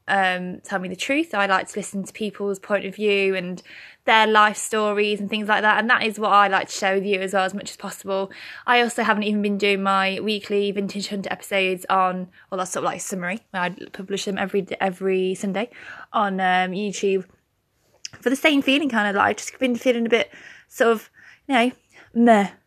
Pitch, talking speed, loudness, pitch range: 200 Hz, 220 wpm, -21 LUFS, 190-215 Hz